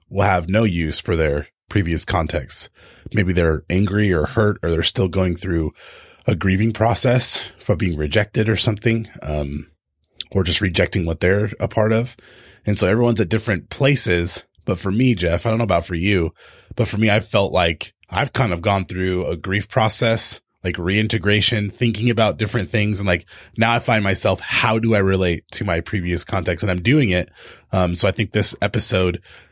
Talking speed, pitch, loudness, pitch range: 195 wpm, 100 Hz, -19 LUFS, 90-110 Hz